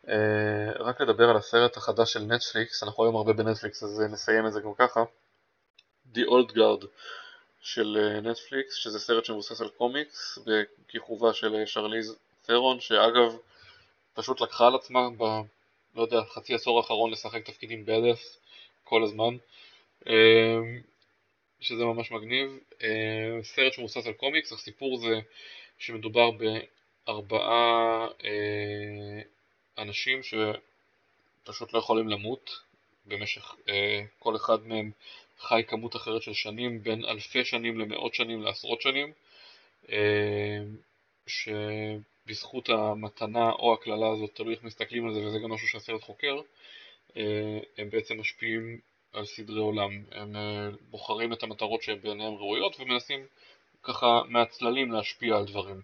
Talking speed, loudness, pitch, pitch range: 125 wpm, -28 LUFS, 110 Hz, 105-115 Hz